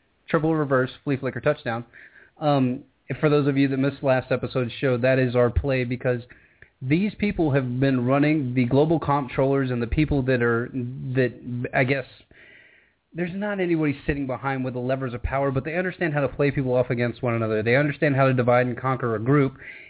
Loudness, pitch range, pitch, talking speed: -23 LUFS, 125-145 Hz, 135 Hz, 200 wpm